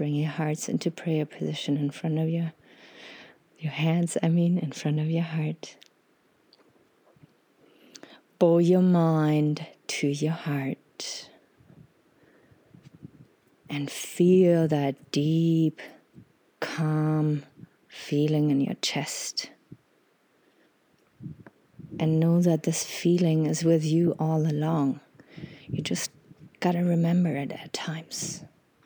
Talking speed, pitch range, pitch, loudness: 110 wpm, 150-170 Hz, 160 Hz, -26 LUFS